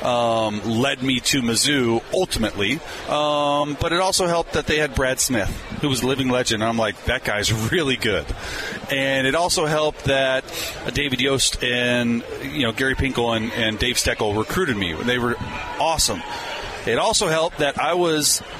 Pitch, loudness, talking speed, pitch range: 130 Hz, -21 LUFS, 180 wpm, 115-145 Hz